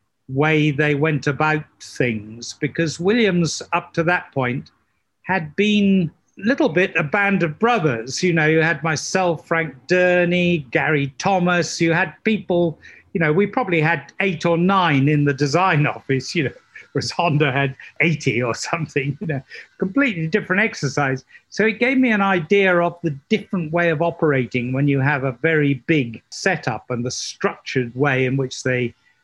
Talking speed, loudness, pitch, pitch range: 170 wpm, -19 LUFS, 160 Hz, 140-180 Hz